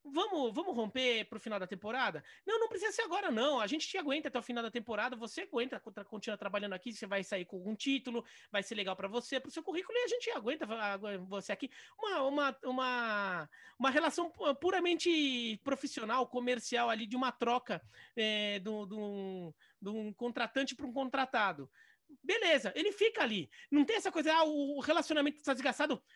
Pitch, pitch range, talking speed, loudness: 255 Hz, 215-305 Hz, 195 wpm, -35 LUFS